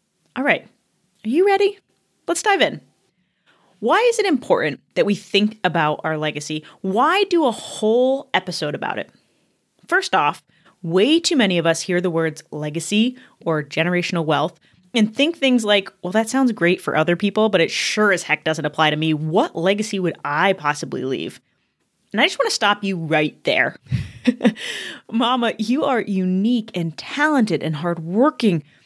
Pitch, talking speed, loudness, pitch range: 200 Hz, 170 wpm, -19 LUFS, 165-245 Hz